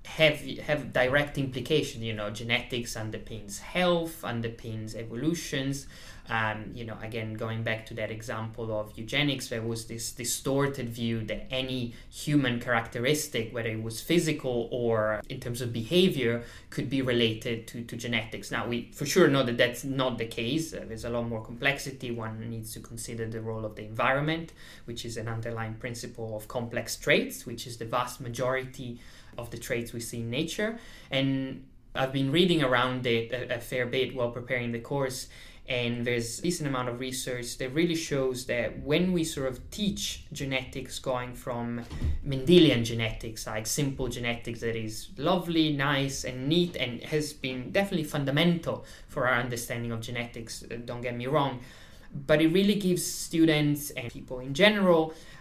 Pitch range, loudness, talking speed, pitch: 115-140 Hz, -29 LUFS, 170 wpm, 125 Hz